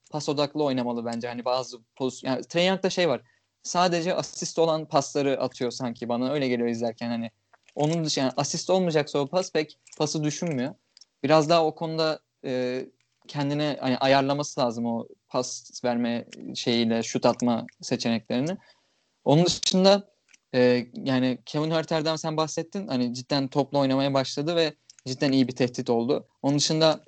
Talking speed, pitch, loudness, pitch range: 150 wpm, 140 Hz, -26 LUFS, 125-155 Hz